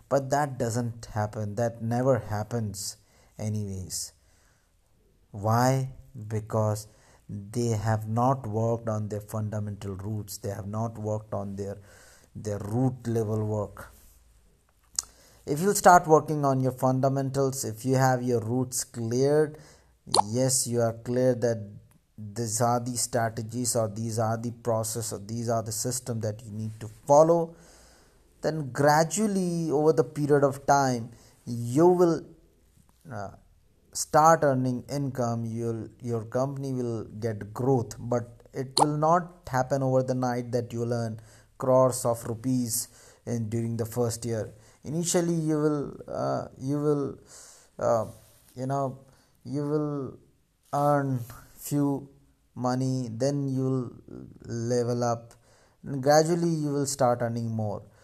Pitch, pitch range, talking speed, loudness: 120 Hz, 110-135 Hz, 135 wpm, -27 LUFS